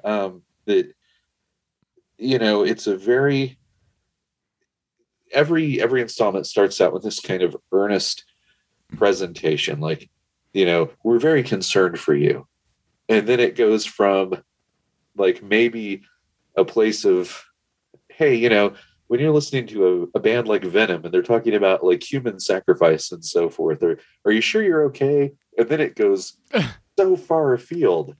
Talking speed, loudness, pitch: 150 wpm, -20 LUFS, 130 Hz